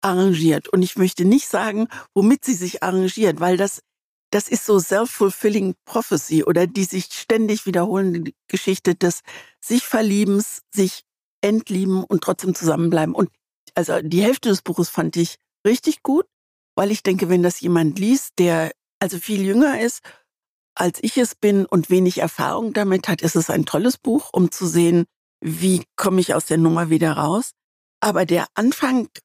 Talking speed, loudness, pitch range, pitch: 165 wpm, -20 LUFS, 175-220 Hz, 190 Hz